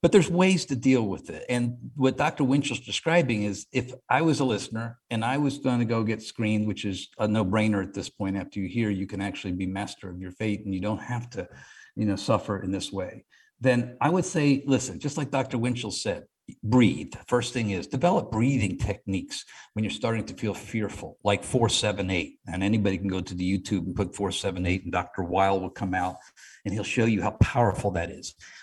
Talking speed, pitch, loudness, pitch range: 225 wpm, 110 Hz, -27 LUFS, 95-125 Hz